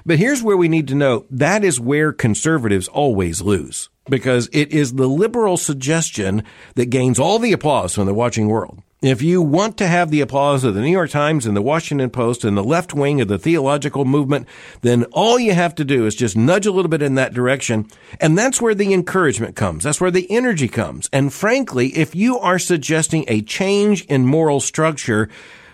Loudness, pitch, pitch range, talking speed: -17 LUFS, 145 Hz, 120-175 Hz, 205 wpm